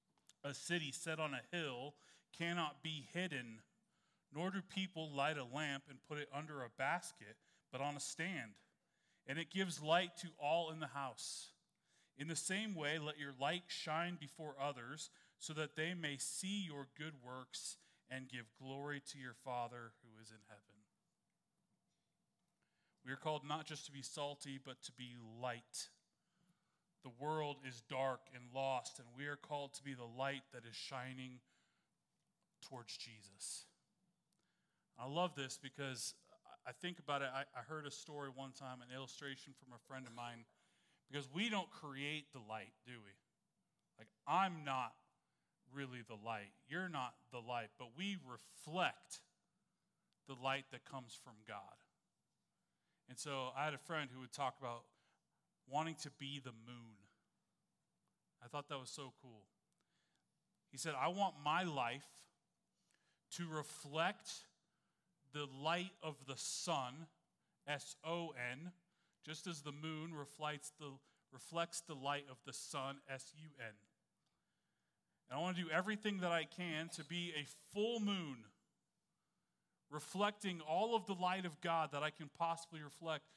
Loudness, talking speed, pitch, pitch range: -45 LUFS, 160 wpm, 145 Hz, 130-170 Hz